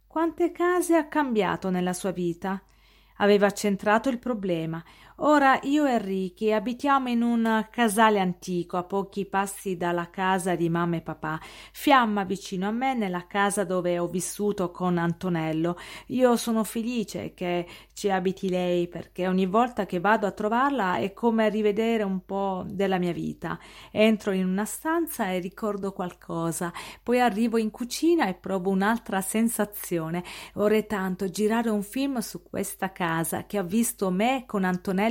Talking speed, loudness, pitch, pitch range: 155 wpm, -26 LUFS, 200 Hz, 185-230 Hz